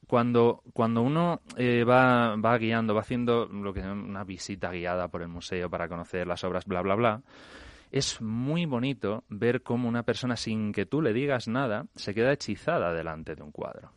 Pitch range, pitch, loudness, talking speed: 95-120 Hz, 110 Hz, -28 LUFS, 190 wpm